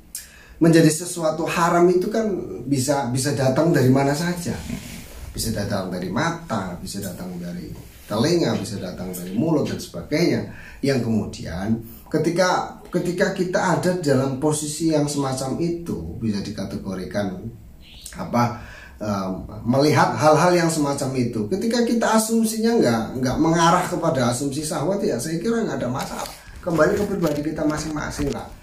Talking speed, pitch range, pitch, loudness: 140 wpm, 115-175 Hz, 150 Hz, -22 LUFS